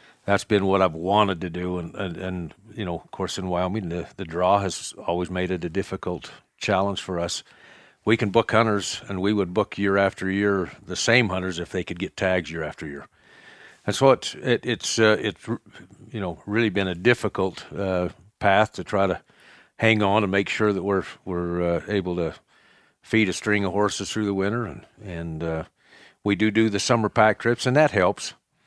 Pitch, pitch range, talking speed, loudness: 100 Hz, 90-105 Hz, 215 wpm, -24 LUFS